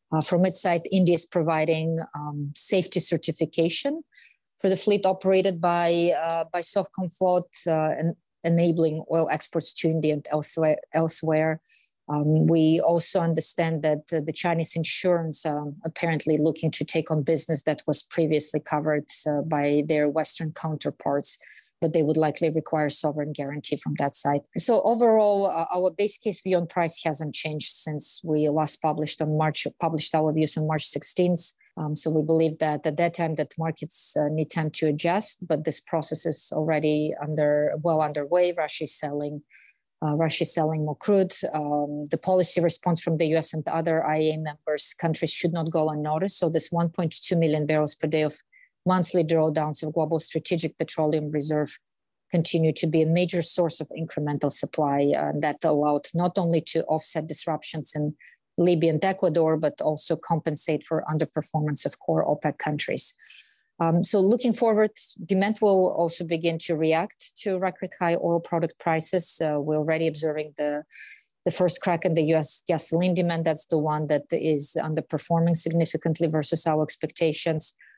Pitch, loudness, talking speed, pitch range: 160 Hz, -24 LUFS, 170 wpm, 155-170 Hz